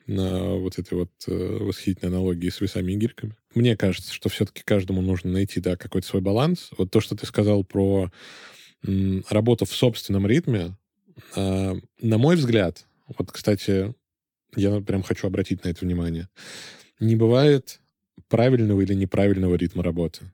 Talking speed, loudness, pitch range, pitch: 155 wpm, -23 LUFS, 90-110 Hz, 100 Hz